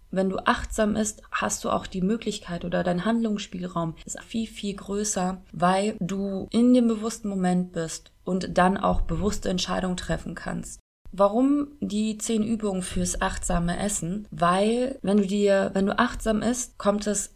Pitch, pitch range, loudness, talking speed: 200 Hz, 185-220 Hz, -26 LUFS, 160 wpm